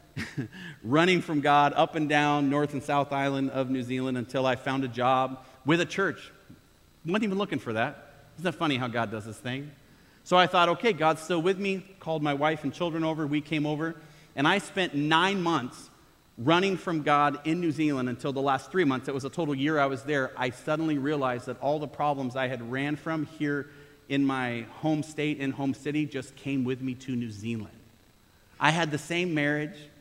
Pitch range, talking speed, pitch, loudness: 130-160 Hz, 215 wpm, 145 Hz, -28 LUFS